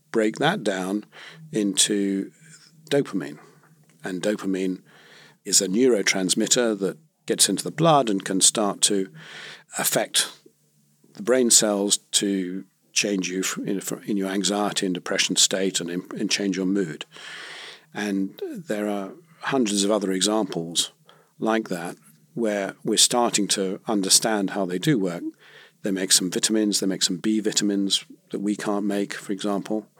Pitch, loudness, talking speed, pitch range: 100 Hz, -22 LUFS, 140 wpm, 95-110 Hz